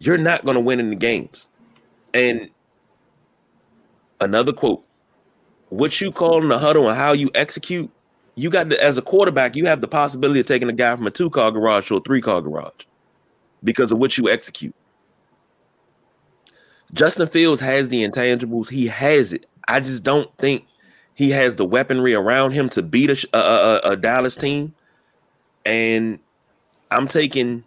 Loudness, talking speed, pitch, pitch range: -18 LUFS, 170 wpm, 135 Hz, 120-150 Hz